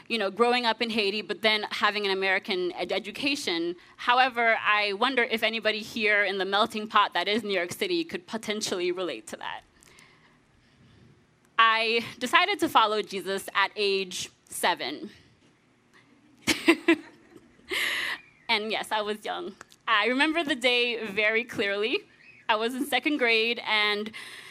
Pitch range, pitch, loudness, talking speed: 200-245 Hz, 215 Hz, -26 LUFS, 140 wpm